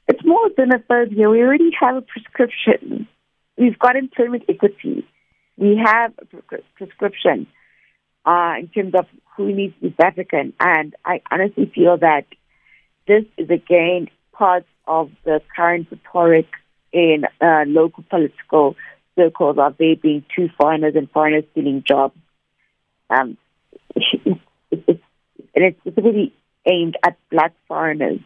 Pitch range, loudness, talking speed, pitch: 160-230 Hz, -17 LUFS, 135 wpm, 180 Hz